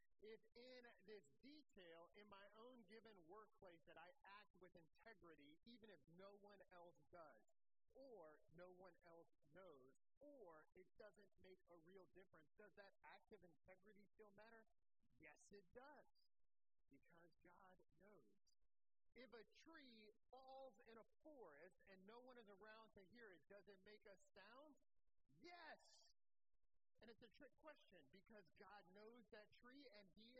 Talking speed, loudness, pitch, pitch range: 150 wpm, -68 LUFS, 205 Hz, 185-235 Hz